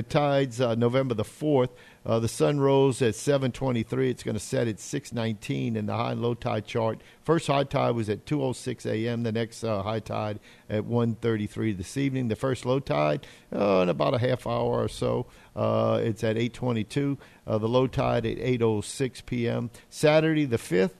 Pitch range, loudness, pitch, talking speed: 110-130 Hz, -27 LUFS, 120 Hz, 225 wpm